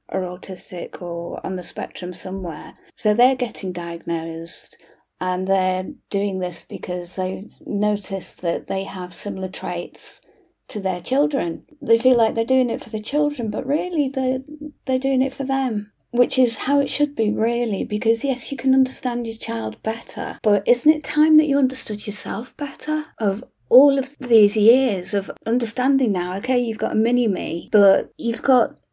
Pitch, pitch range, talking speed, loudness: 225 Hz, 190-265 Hz, 175 wpm, -21 LUFS